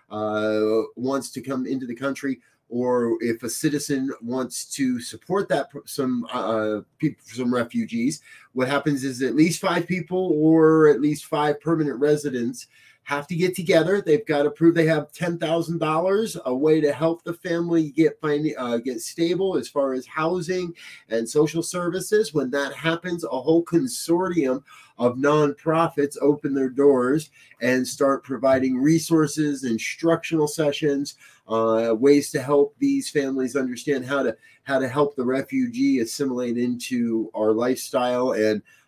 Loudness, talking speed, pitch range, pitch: -23 LUFS, 155 wpm, 130-165 Hz, 145 Hz